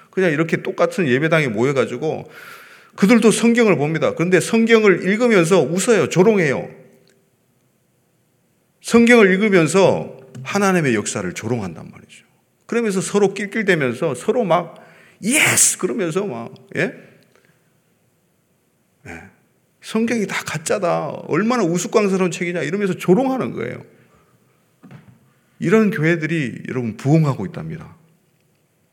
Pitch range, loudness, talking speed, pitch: 170-220 Hz, -17 LUFS, 280 characters per minute, 185 Hz